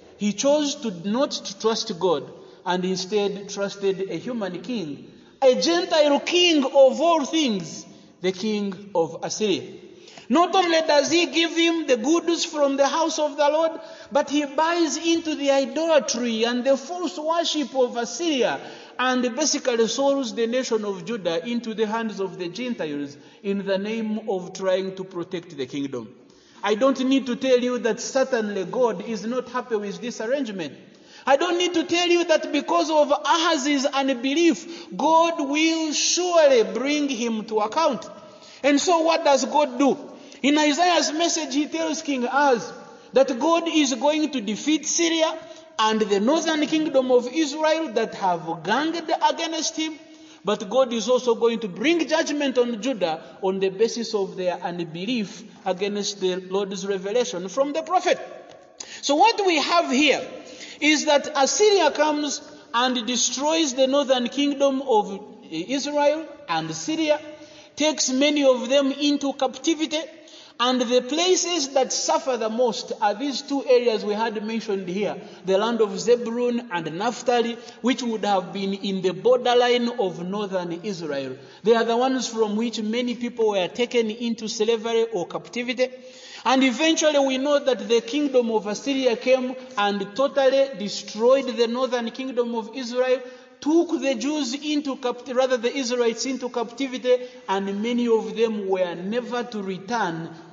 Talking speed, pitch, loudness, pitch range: 155 wpm, 255 Hz, -22 LUFS, 220-300 Hz